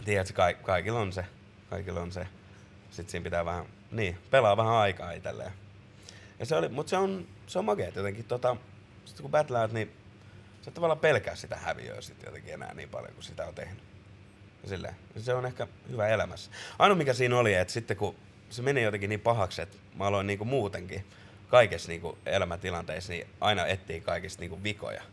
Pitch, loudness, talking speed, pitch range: 100 Hz, -30 LUFS, 190 wpm, 95-115 Hz